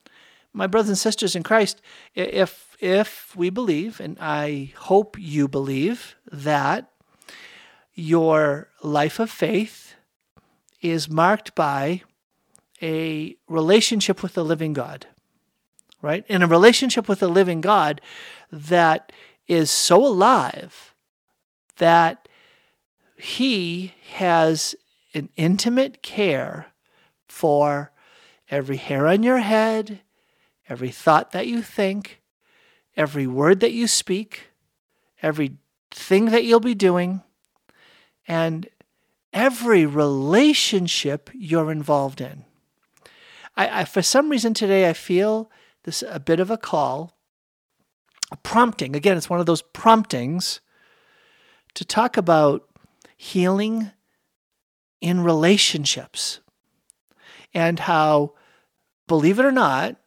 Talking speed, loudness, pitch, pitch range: 110 wpm, -20 LUFS, 185 Hz, 160-225 Hz